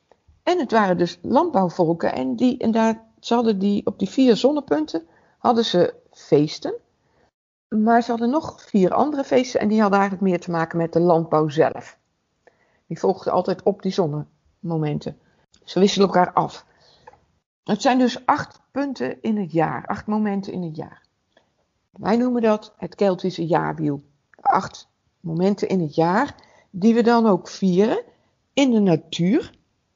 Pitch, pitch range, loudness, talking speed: 200 Hz, 170-235 Hz, -21 LUFS, 155 wpm